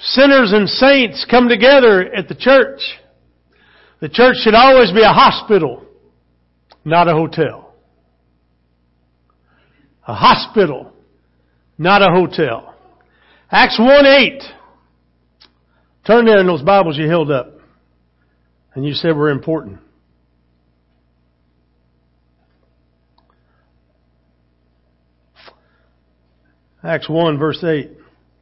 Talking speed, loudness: 90 wpm, -12 LUFS